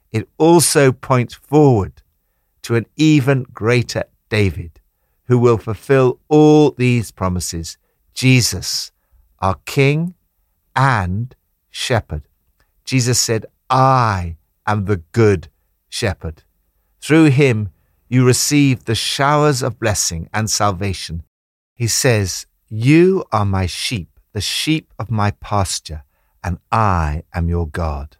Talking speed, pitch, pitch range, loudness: 115 wpm, 105 Hz, 85-130 Hz, -16 LUFS